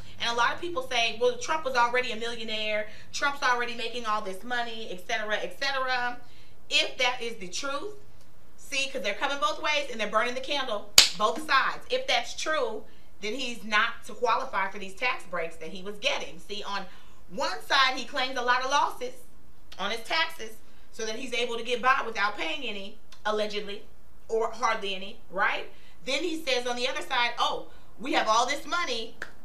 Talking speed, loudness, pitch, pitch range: 200 wpm, -28 LUFS, 240 Hz, 215-270 Hz